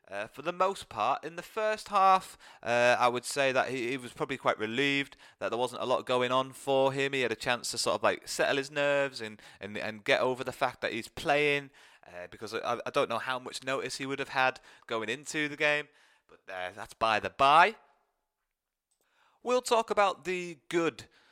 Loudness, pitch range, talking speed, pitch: -30 LUFS, 125-170 Hz, 220 wpm, 135 Hz